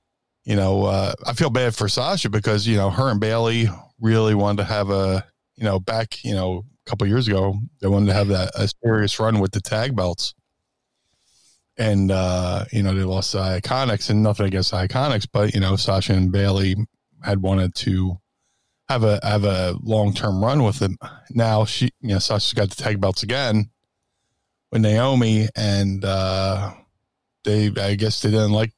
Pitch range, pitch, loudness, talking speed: 95-115 Hz, 105 Hz, -21 LUFS, 190 wpm